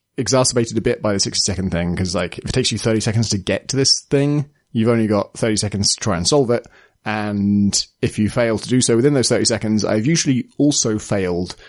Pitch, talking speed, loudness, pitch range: 115 Hz, 235 wpm, -18 LUFS, 105-125 Hz